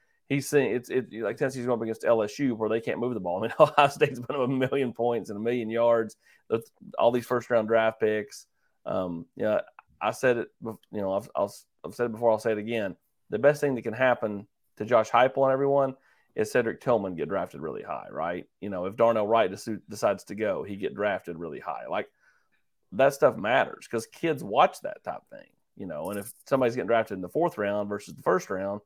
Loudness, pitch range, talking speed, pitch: -27 LUFS, 110-130 Hz, 235 wpm, 115 Hz